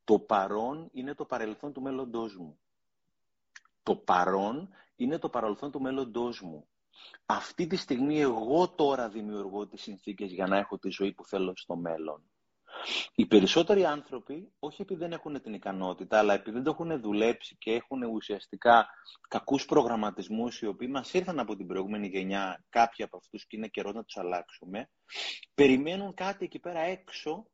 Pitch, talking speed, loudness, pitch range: 115 Hz, 165 wpm, -31 LUFS, 100-145 Hz